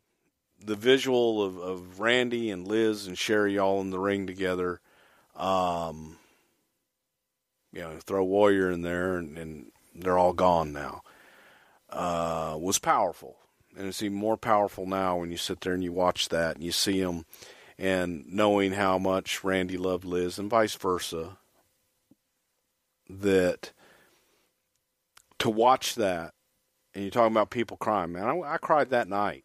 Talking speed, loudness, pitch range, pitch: 150 wpm, -27 LUFS, 90-105 Hz, 95 Hz